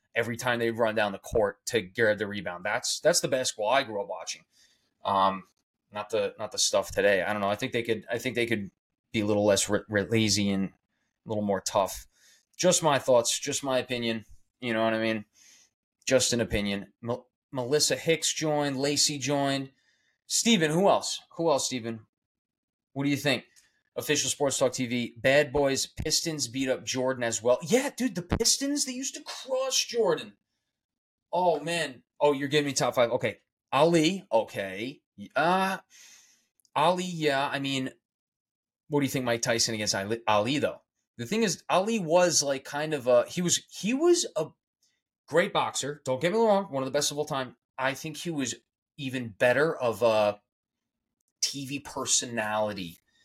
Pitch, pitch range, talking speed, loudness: 135 Hz, 115-155 Hz, 185 wpm, -27 LUFS